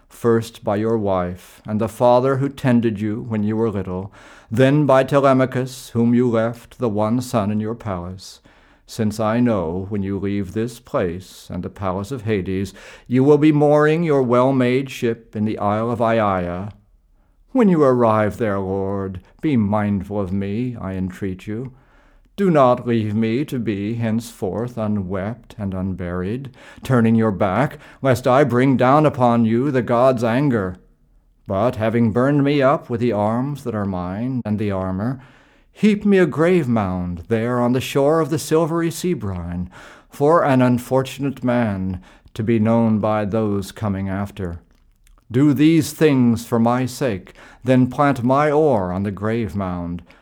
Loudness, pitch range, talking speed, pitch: -19 LUFS, 100-130 Hz, 165 wpm, 115 Hz